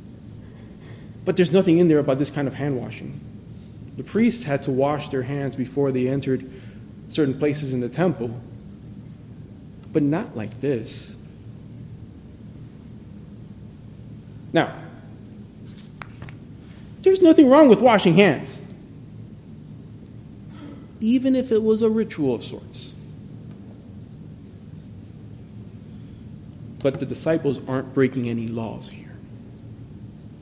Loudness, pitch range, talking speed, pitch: -21 LUFS, 115-150 Hz, 105 wpm, 130 Hz